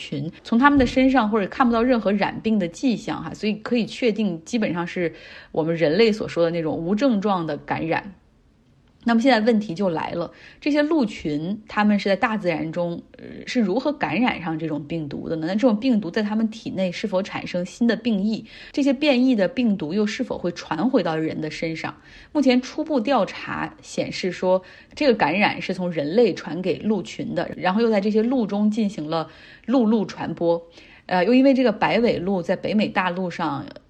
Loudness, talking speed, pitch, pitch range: -22 LUFS, 295 characters per minute, 215 Hz, 175-250 Hz